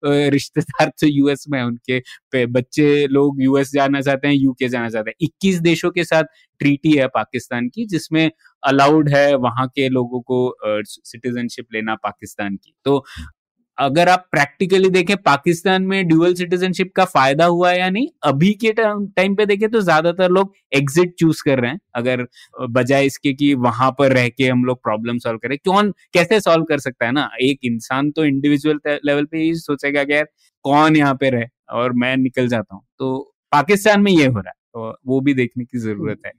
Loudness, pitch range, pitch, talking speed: -17 LUFS, 125-165 Hz, 140 Hz, 190 wpm